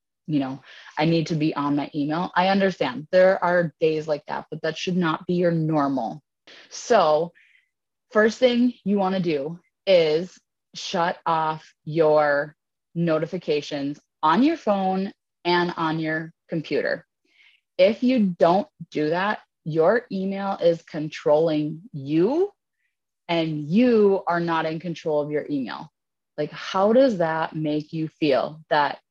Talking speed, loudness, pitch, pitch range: 140 wpm, -23 LUFS, 165 Hz, 155-190 Hz